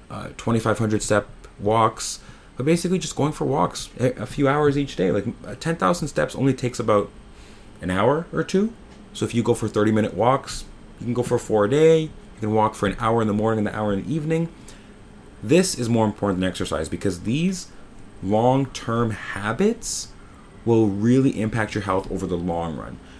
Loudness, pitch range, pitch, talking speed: -22 LUFS, 105-140 Hz, 110 Hz, 195 wpm